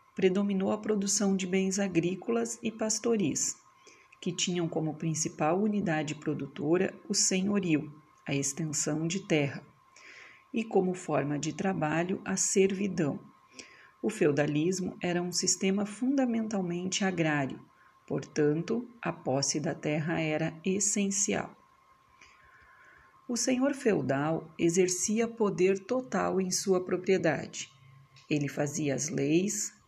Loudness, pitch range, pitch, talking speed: -30 LUFS, 155-200 Hz, 185 Hz, 110 wpm